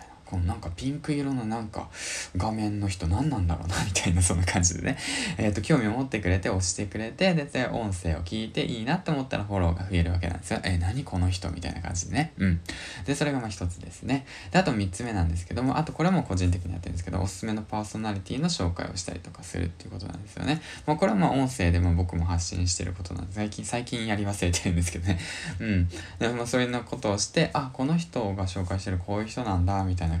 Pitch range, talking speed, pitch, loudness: 90-120 Hz, 495 characters per minute, 95 Hz, -28 LUFS